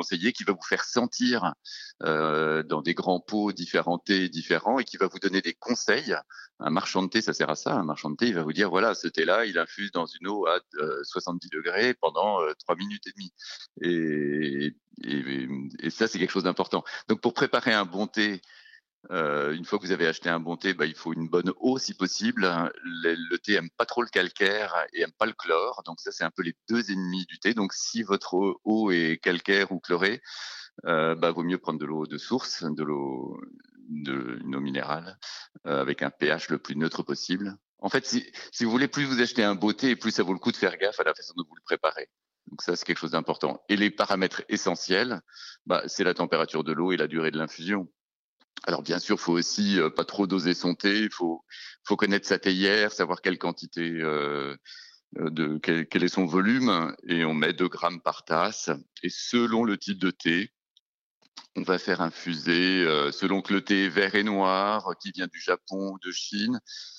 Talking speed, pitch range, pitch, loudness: 220 wpm, 80-105 Hz, 95 Hz, -27 LUFS